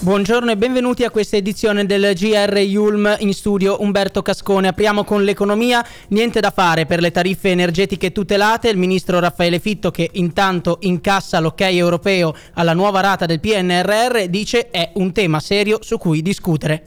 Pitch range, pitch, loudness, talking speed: 180-210 Hz, 195 Hz, -16 LUFS, 165 wpm